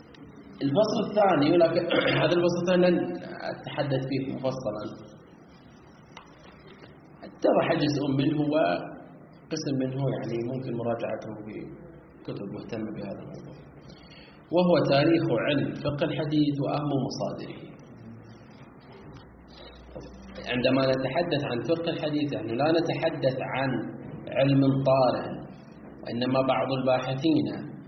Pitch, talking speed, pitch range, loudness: 135 Hz, 95 wpm, 125-160 Hz, -26 LUFS